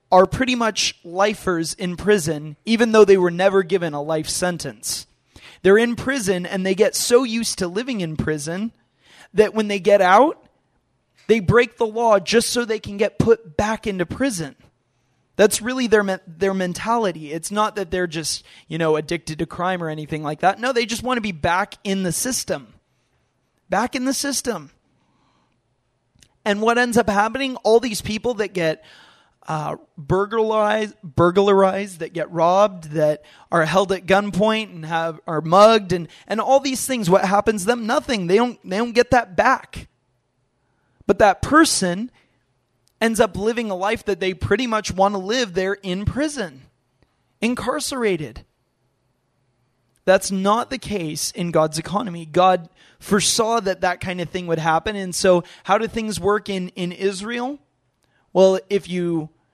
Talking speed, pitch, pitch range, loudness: 170 wpm, 195 Hz, 165-220 Hz, -20 LUFS